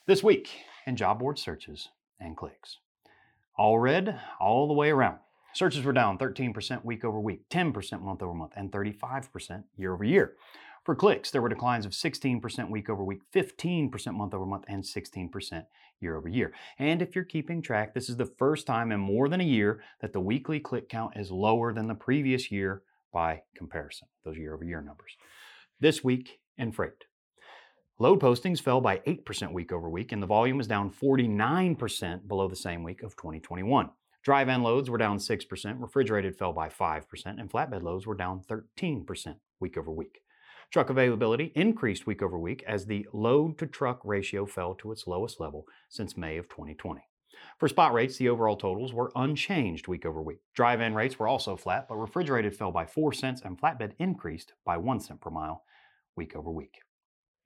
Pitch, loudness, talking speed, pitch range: 110 Hz, -30 LUFS, 185 wpm, 95-135 Hz